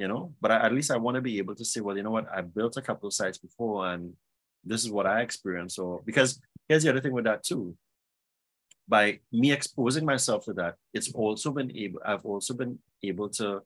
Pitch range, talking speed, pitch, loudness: 100-130 Hz, 235 wpm, 110 Hz, -29 LUFS